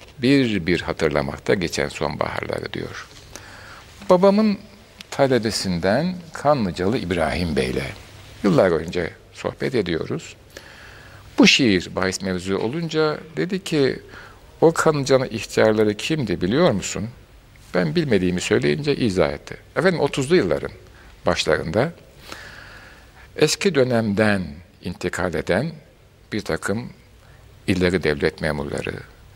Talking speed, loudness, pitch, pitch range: 95 wpm, -21 LUFS, 115 Hz, 95-155 Hz